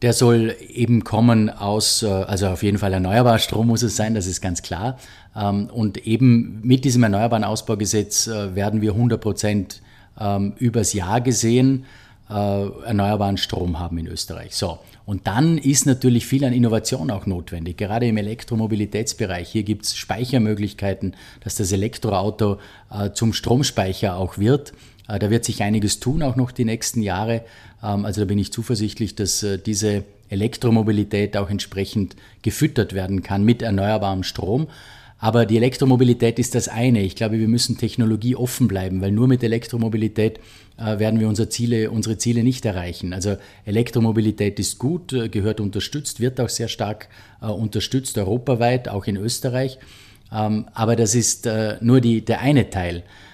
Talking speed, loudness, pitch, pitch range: 150 wpm, -21 LUFS, 110 Hz, 100-120 Hz